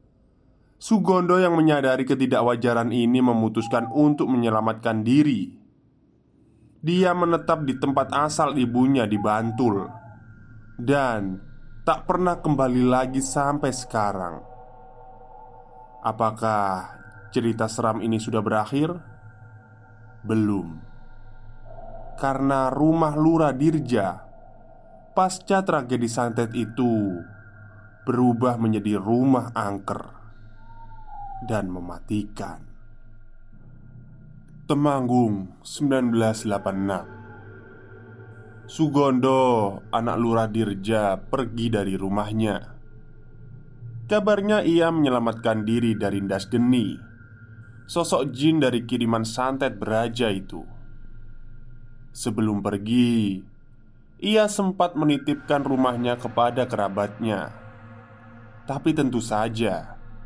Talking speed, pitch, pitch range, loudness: 80 wpm, 120 Hz, 110-135 Hz, -23 LUFS